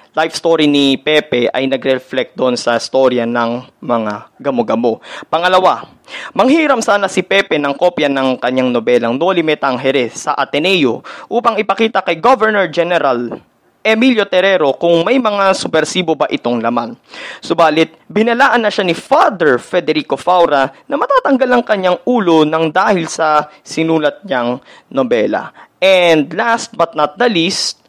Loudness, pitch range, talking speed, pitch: -13 LUFS, 135-195 Hz, 140 wpm, 165 Hz